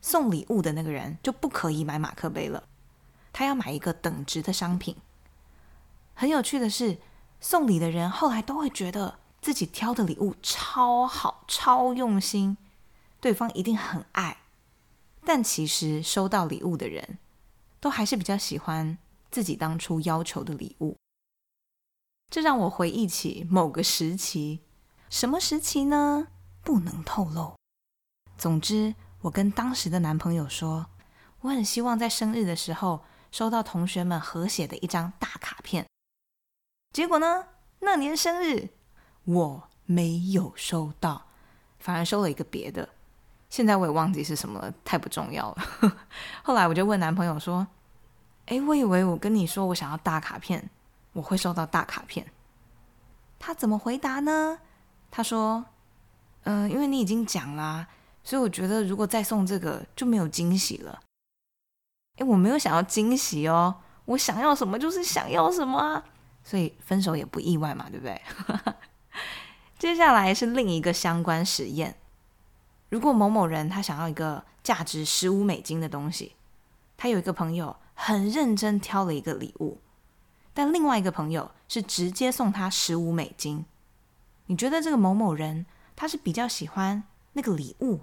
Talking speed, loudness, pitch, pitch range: 235 characters per minute, -27 LUFS, 185 Hz, 160-230 Hz